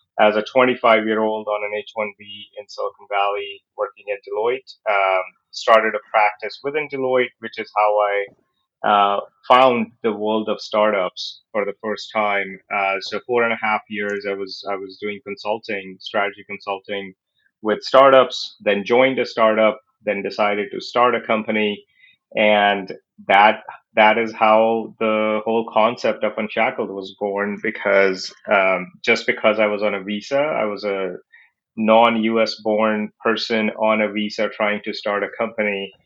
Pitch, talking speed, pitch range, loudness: 105 Hz, 165 wpm, 100-115 Hz, -19 LUFS